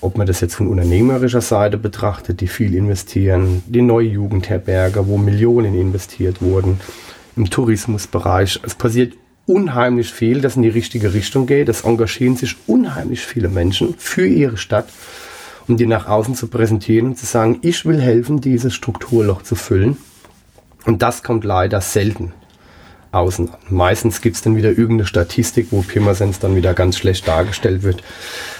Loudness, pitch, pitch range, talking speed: -16 LUFS, 105 Hz, 95-120 Hz, 160 wpm